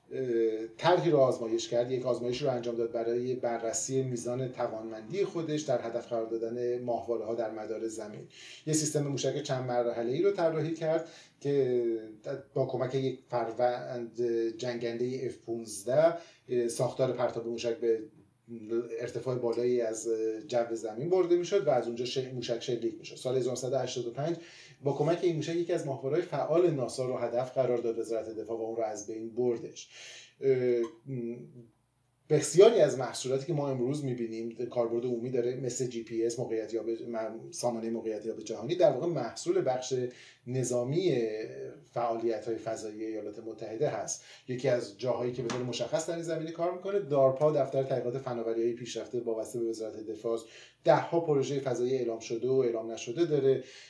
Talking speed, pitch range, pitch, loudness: 160 wpm, 115-135 Hz, 120 Hz, -32 LUFS